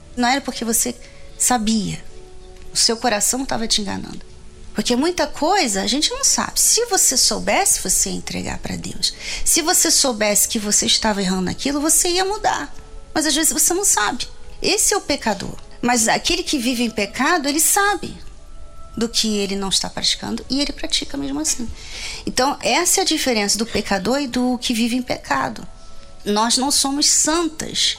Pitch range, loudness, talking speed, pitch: 225-320 Hz, -18 LUFS, 180 wpm, 260 Hz